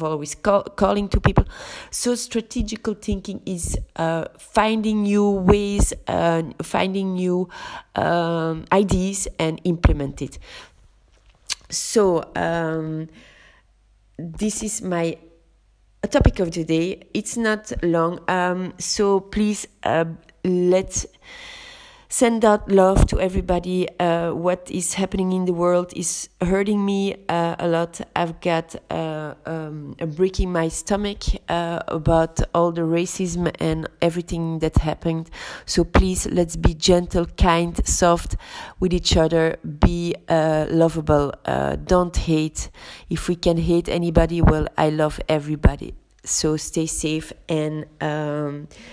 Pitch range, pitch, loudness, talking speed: 160-190 Hz, 170 Hz, -22 LUFS, 125 wpm